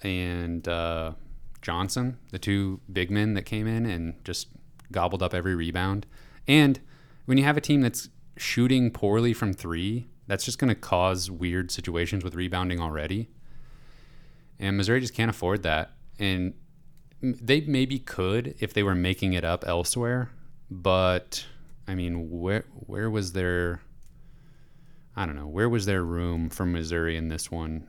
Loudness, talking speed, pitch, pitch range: -27 LUFS, 155 wpm, 95 Hz, 90-120 Hz